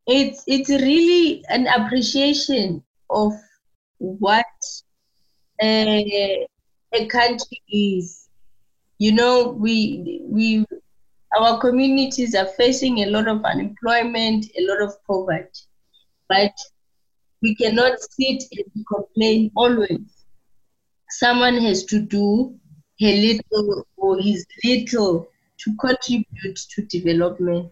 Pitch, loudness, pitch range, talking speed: 220 Hz, -19 LUFS, 200-245 Hz, 100 wpm